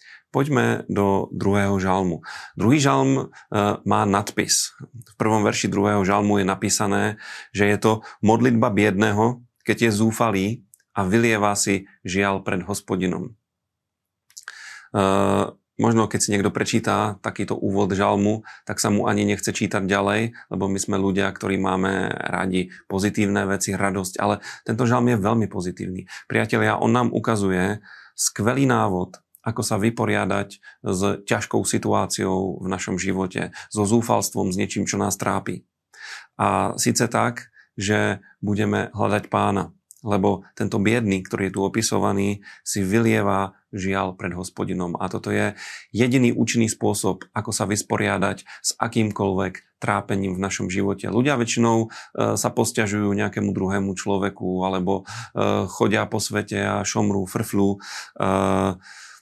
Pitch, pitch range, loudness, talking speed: 100 Hz, 95-110 Hz, -22 LUFS, 135 wpm